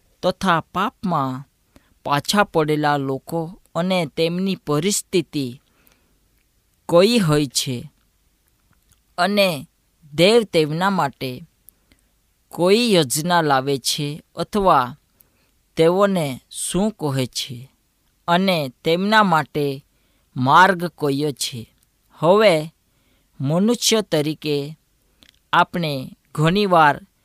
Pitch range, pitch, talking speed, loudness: 140-180 Hz, 160 Hz, 75 wpm, -19 LUFS